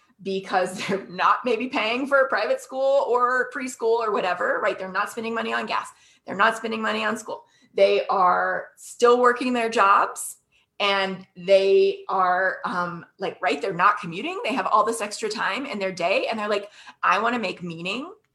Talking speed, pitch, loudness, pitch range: 185 wpm, 220 Hz, -23 LUFS, 195-250 Hz